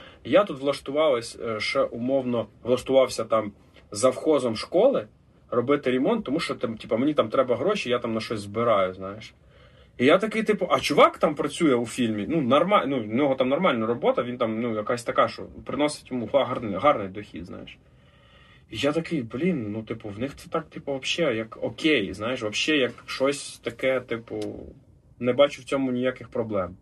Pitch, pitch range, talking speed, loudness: 125 Hz, 110-140 Hz, 180 wpm, -25 LUFS